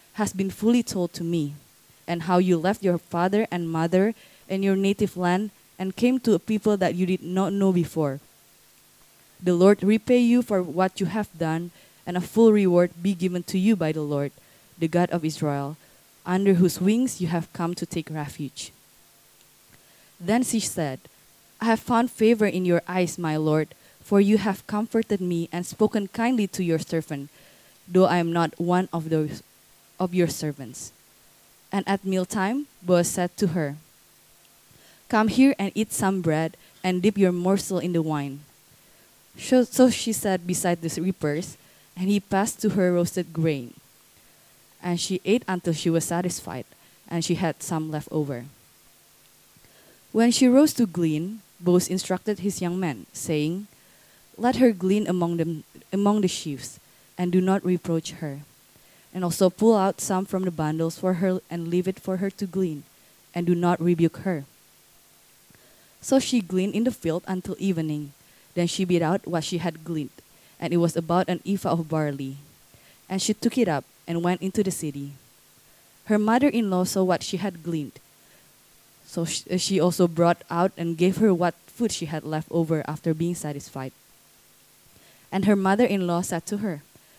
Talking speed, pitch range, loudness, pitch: 175 wpm, 165-195 Hz, -24 LUFS, 180 Hz